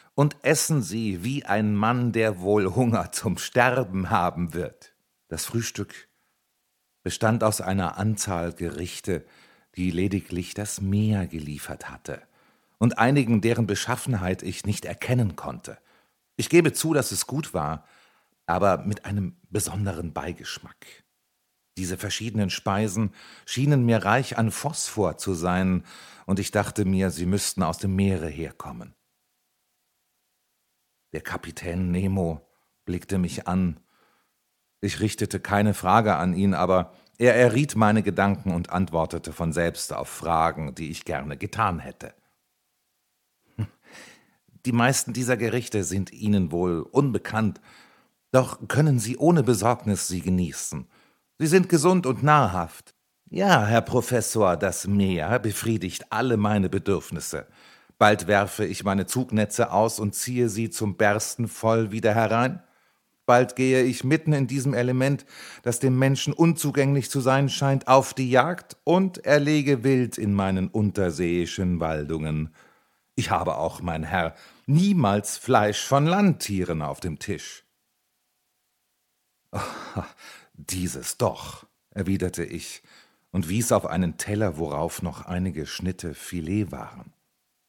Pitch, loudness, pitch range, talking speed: 105 Hz, -24 LUFS, 90-125 Hz, 130 wpm